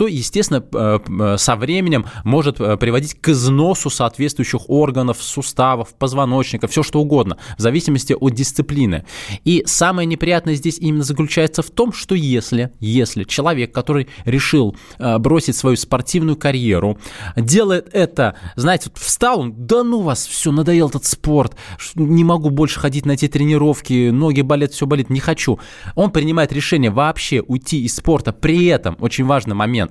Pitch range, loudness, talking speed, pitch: 120-155 Hz, -16 LUFS, 150 wpm, 140 Hz